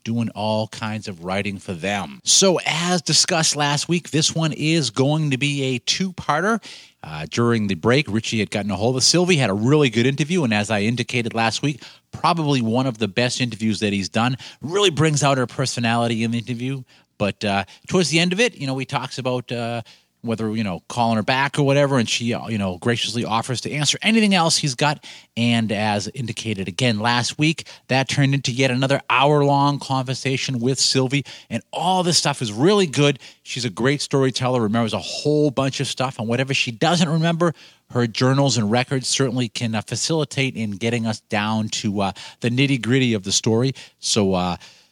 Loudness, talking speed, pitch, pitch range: -20 LUFS, 205 wpm, 125 Hz, 115-145 Hz